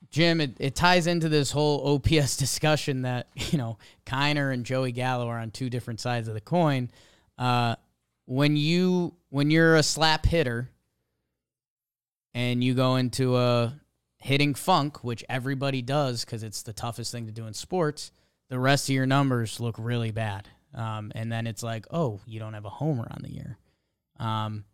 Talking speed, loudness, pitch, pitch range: 180 wpm, -26 LUFS, 125 Hz, 115-145 Hz